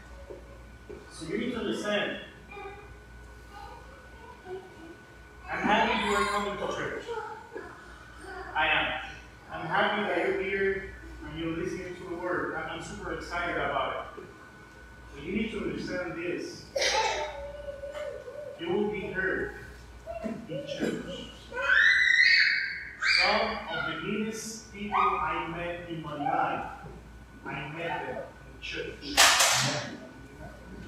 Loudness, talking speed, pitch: -28 LUFS, 110 wpm, 205 Hz